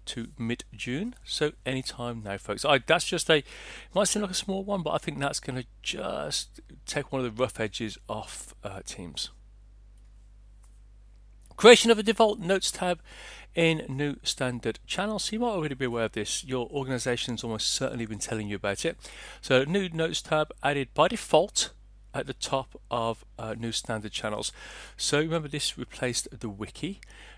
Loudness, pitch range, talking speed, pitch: -28 LUFS, 110-155 Hz, 180 wpm, 125 Hz